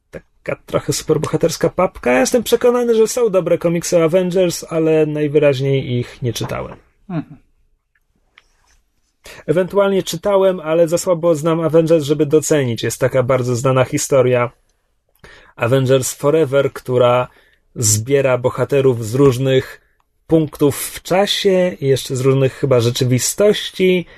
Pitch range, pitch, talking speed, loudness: 130-170 Hz, 150 Hz, 115 wpm, -16 LUFS